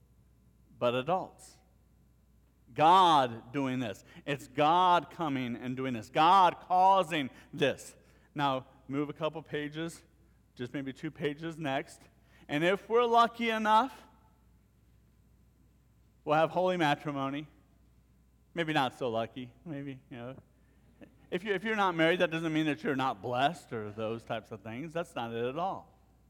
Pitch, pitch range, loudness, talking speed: 145 Hz, 120-170 Hz, -30 LUFS, 140 wpm